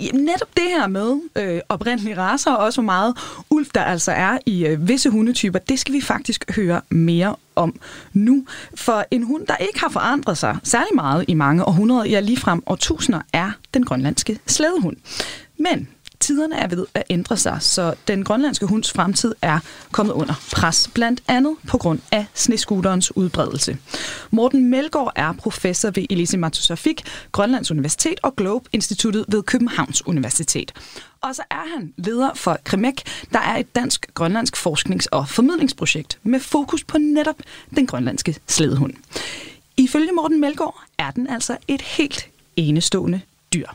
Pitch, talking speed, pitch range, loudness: 225 Hz, 155 wpm, 180-270 Hz, -19 LUFS